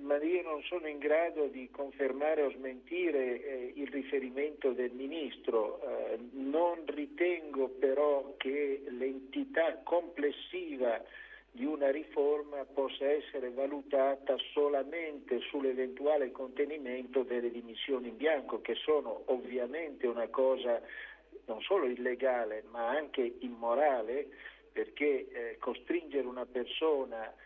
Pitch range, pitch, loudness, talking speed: 130-170 Hz, 140 Hz, -35 LUFS, 110 wpm